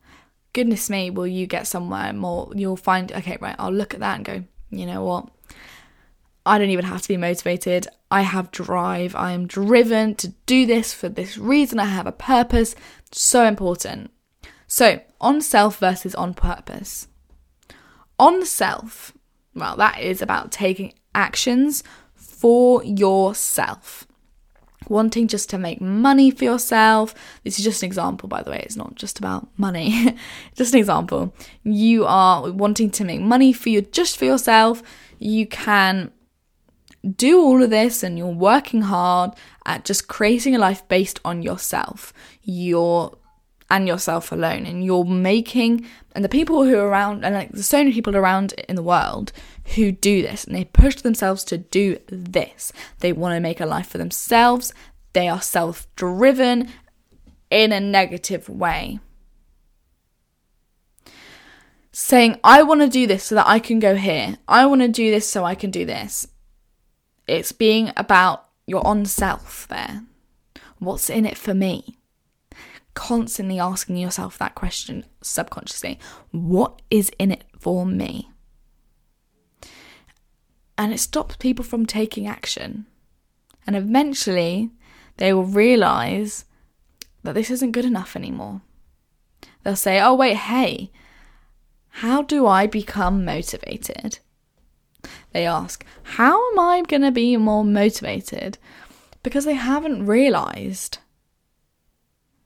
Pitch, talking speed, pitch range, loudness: 205 Hz, 145 wpm, 185-240 Hz, -19 LUFS